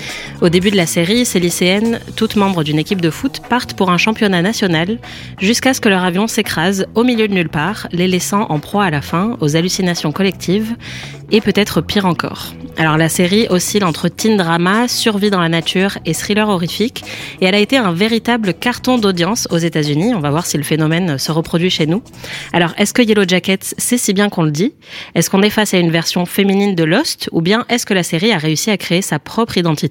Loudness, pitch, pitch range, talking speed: -14 LUFS, 190 Hz, 165-215 Hz, 225 wpm